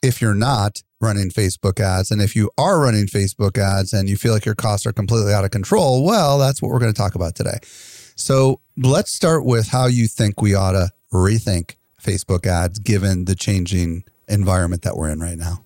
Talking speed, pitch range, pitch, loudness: 210 wpm, 95-120 Hz, 105 Hz, -18 LUFS